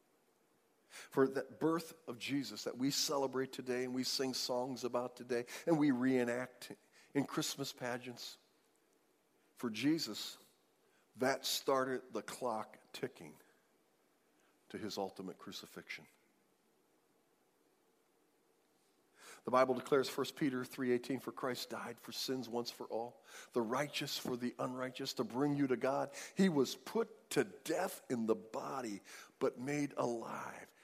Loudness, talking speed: -39 LUFS, 130 wpm